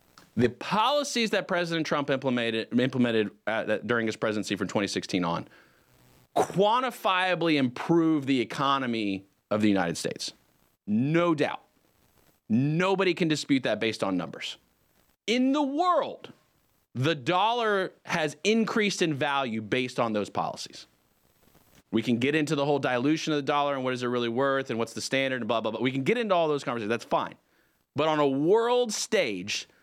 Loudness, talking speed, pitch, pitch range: -27 LUFS, 165 wpm, 145 Hz, 120-180 Hz